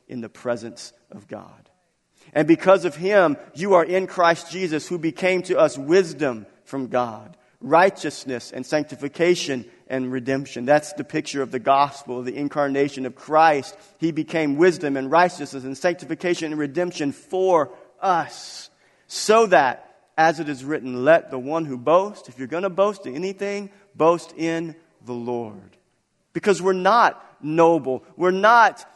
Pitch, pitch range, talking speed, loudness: 160 Hz, 135-185 Hz, 155 wpm, -21 LUFS